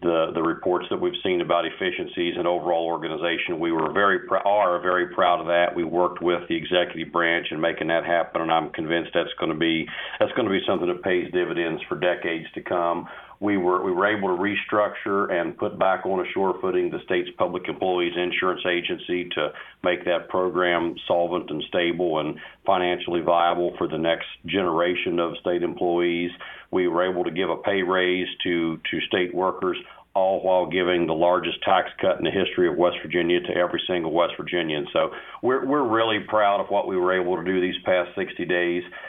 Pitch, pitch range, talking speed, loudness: 90 Hz, 85-95 Hz, 205 wpm, -24 LUFS